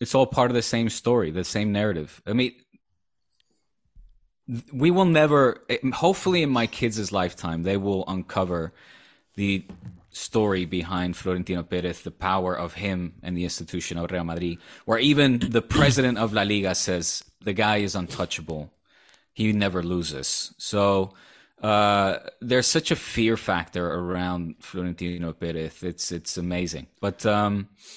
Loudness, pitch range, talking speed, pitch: -24 LUFS, 90-115 Hz, 145 wpm, 95 Hz